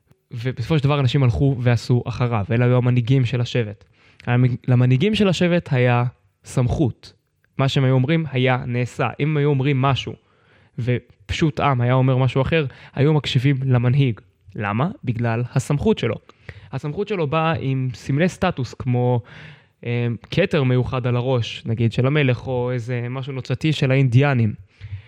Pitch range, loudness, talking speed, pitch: 120-140 Hz, -20 LUFS, 145 wpm, 130 Hz